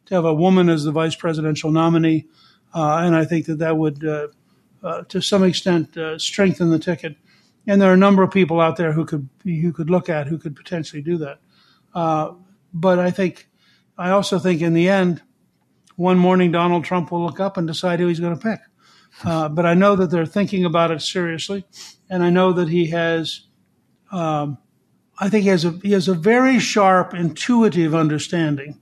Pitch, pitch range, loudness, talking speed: 175 Hz, 160-185 Hz, -19 LUFS, 205 wpm